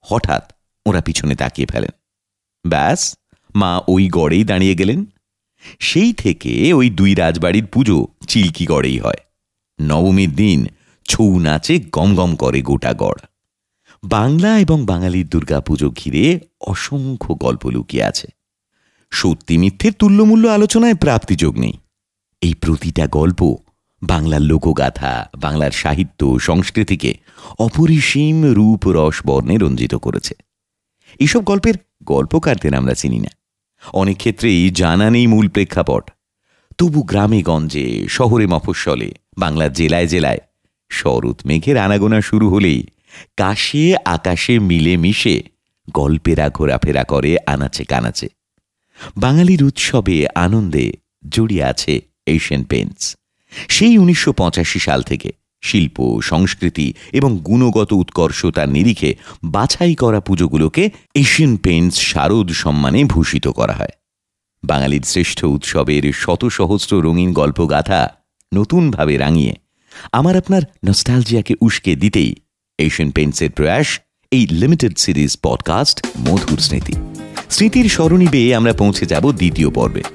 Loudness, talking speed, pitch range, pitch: -15 LUFS, 110 wpm, 75-115 Hz, 90 Hz